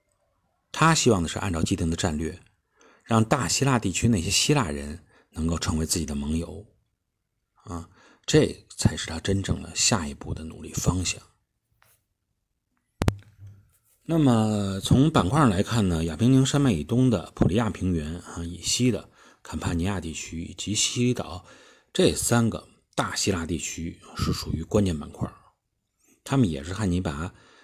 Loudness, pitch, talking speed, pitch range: -25 LUFS, 100 Hz, 230 characters per minute, 85-115 Hz